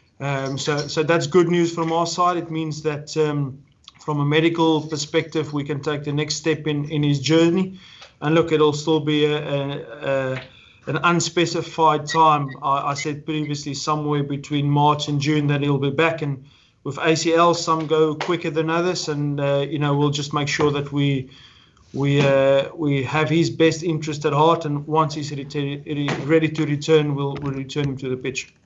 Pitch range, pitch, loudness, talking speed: 145-160 Hz, 150 Hz, -21 LUFS, 195 wpm